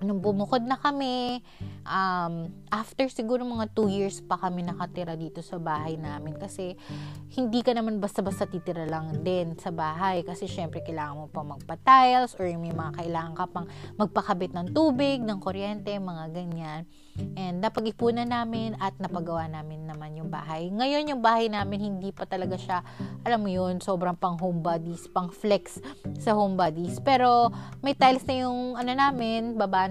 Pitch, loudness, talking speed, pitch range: 185 Hz, -28 LUFS, 165 wpm, 170-225 Hz